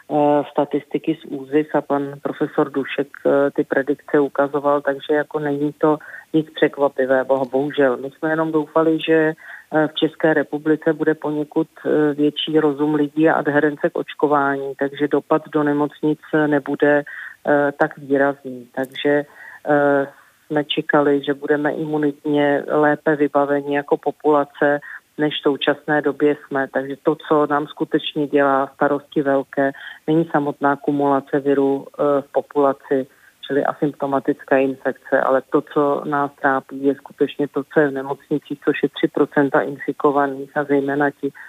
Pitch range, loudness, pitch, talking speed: 140-150 Hz, -19 LUFS, 145 Hz, 135 wpm